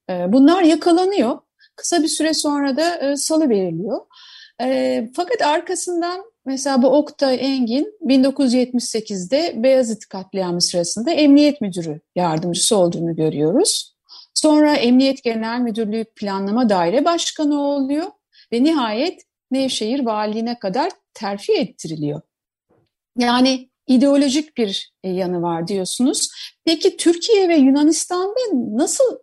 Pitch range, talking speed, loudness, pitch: 220-315 Hz, 105 wpm, -18 LUFS, 265 Hz